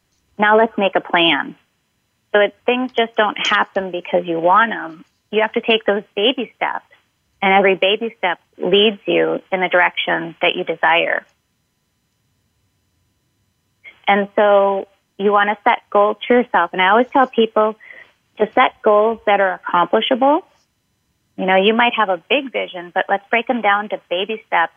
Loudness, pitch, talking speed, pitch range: -16 LUFS, 200 Hz, 170 wpm, 175-220 Hz